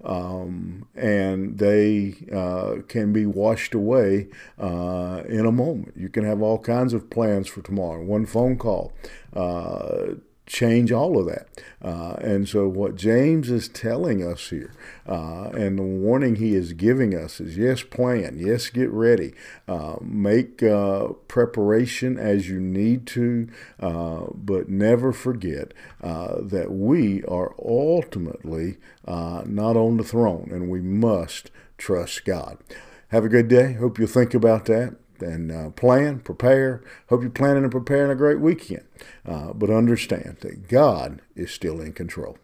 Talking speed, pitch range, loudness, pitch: 155 wpm, 95-120 Hz, -22 LUFS, 105 Hz